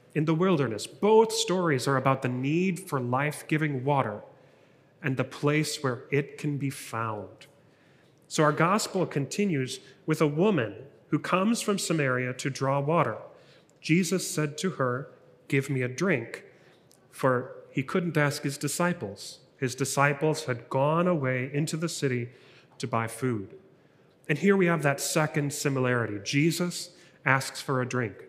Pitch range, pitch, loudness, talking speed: 130-170 Hz, 145 Hz, -28 LUFS, 155 wpm